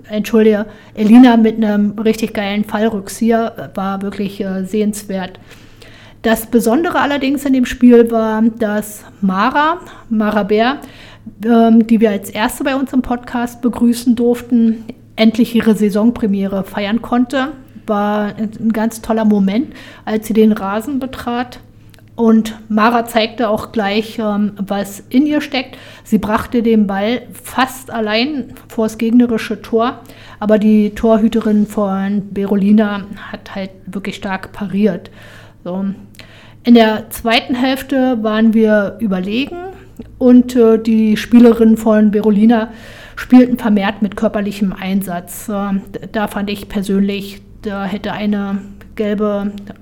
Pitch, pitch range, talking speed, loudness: 220 Hz, 205-235 Hz, 125 wpm, -14 LUFS